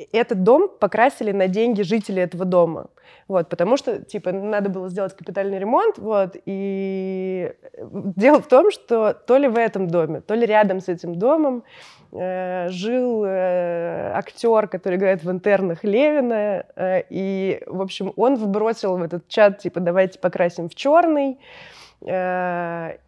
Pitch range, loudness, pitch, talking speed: 185-230 Hz, -20 LUFS, 195 Hz, 150 wpm